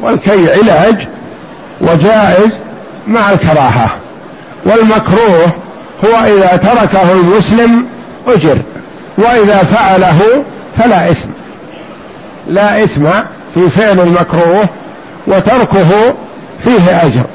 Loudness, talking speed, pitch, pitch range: -8 LUFS, 80 wpm, 195 Hz, 175-220 Hz